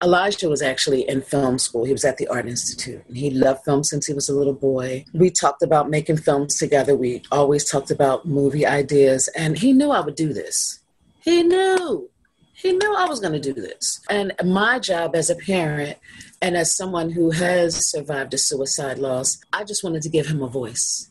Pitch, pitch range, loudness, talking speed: 150 Hz, 135-180 Hz, -20 LUFS, 210 wpm